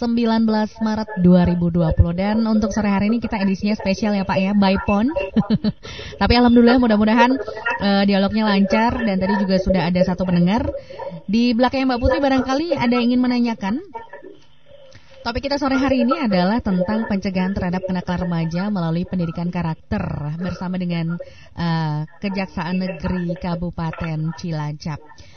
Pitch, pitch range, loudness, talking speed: 195 Hz, 180-235 Hz, -19 LUFS, 140 wpm